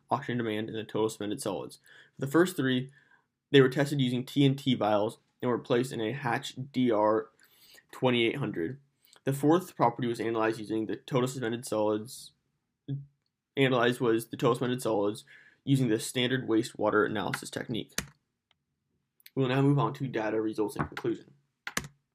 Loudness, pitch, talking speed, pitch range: -30 LUFS, 125 Hz, 150 wpm, 110-140 Hz